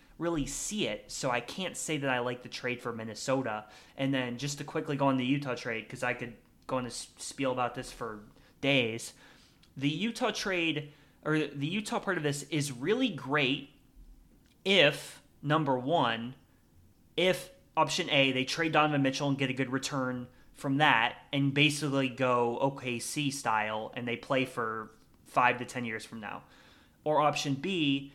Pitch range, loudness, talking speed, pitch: 125-150 Hz, -31 LUFS, 175 wpm, 135 Hz